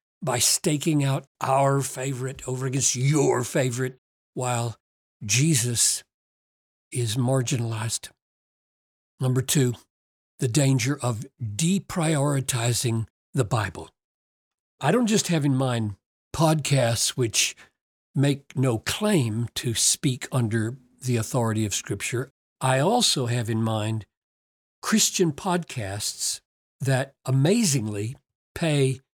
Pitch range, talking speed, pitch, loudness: 115-140 Hz, 100 wpm, 130 Hz, -24 LUFS